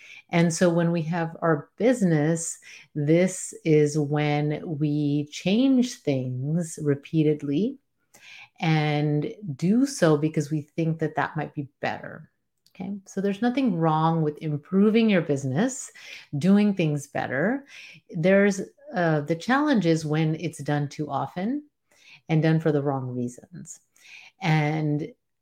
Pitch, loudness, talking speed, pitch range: 160 Hz, -25 LUFS, 125 wpm, 150-190 Hz